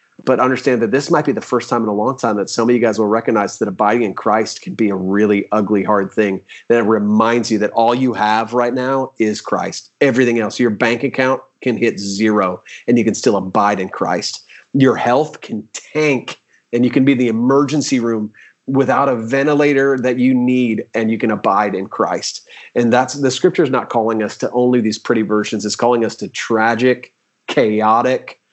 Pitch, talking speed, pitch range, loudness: 120 Hz, 210 wpm, 110-130 Hz, -16 LUFS